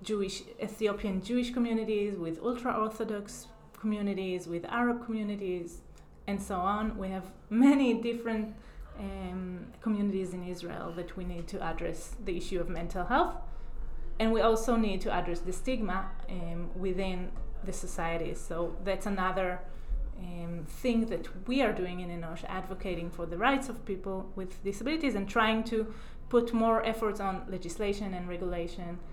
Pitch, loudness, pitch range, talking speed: 195 Hz, -33 LUFS, 180-220 Hz, 150 wpm